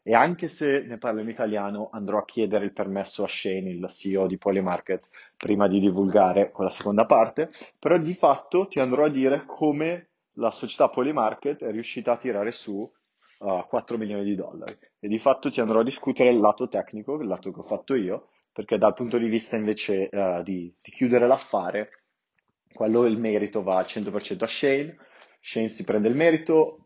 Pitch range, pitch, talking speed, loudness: 100-135 Hz, 110 Hz, 190 wpm, -25 LUFS